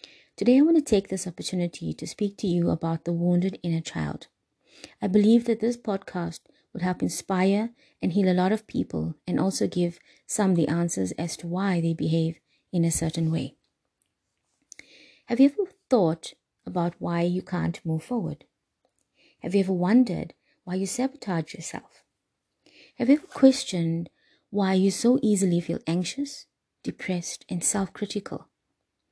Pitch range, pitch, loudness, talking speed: 170-215 Hz, 185 Hz, -26 LUFS, 160 wpm